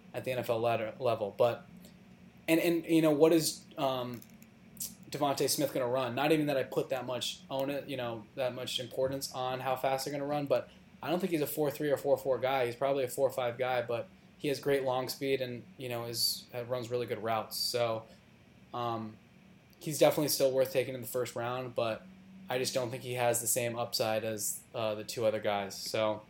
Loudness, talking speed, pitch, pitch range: -33 LUFS, 230 wpm, 130 Hz, 120-140 Hz